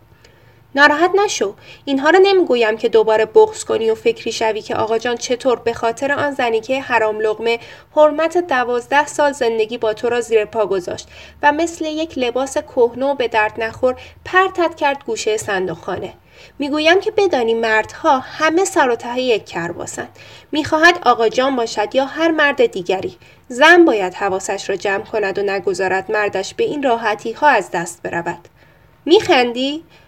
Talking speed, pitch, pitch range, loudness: 165 wpm, 245 Hz, 215-310 Hz, -16 LUFS